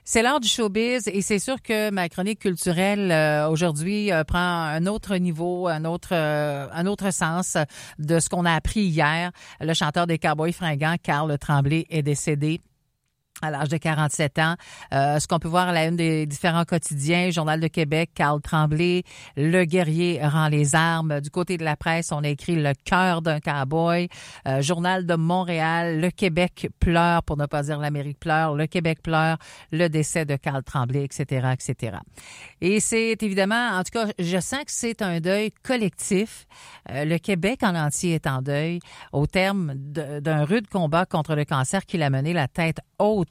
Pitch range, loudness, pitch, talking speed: 150-185 Hz, -23 LUFS, 165 Hz, 185 wpm